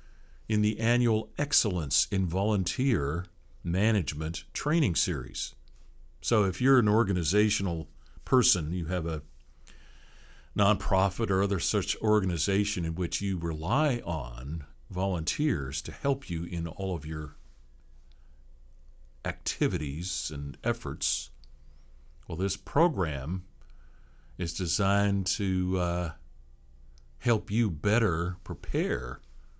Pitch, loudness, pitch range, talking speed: 85 Hz, -29 LUFS, 65-100 Hz, 100 wpm